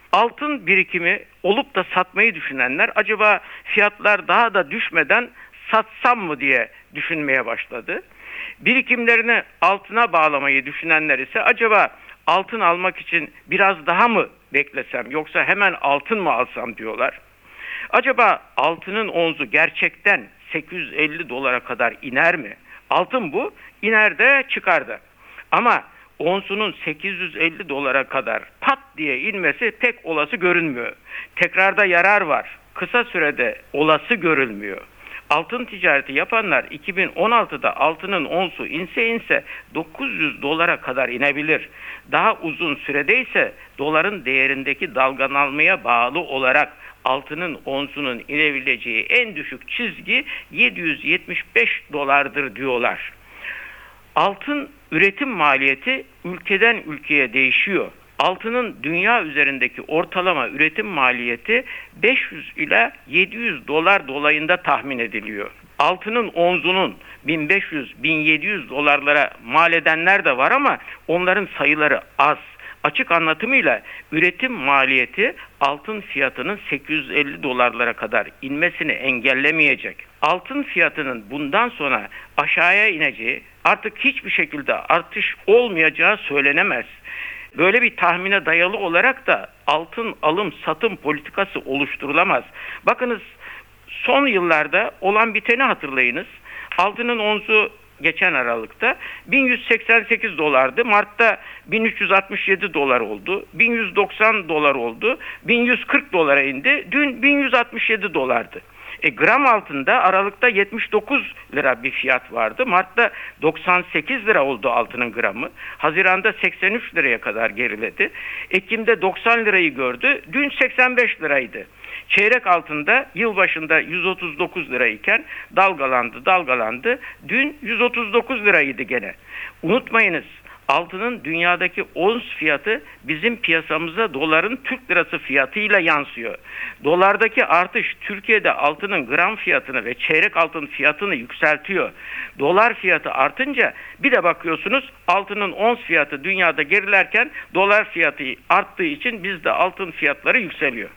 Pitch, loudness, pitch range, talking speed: 185 Hz, -18 LUFS, 150-225 Hz, 105 wpm